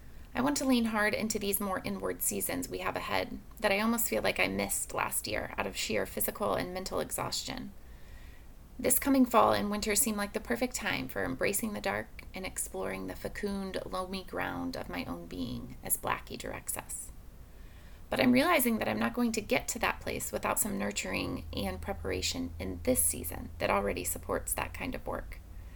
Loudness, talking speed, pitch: -32 LUFS, 195 wpm, 100 Hz